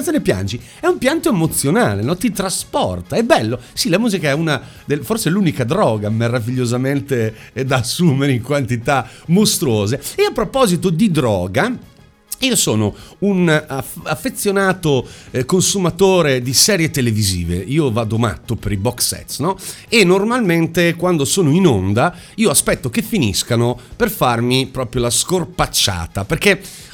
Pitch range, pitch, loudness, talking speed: 120-185 Hz, 145 Hz, -16 LUFS, 145 wpm